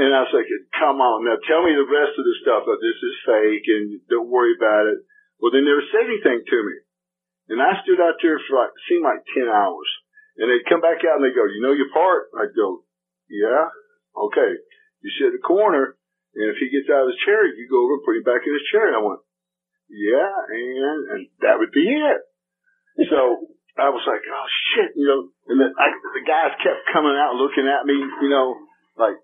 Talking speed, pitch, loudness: 230 wpm, 355 Hz, -19 LUFS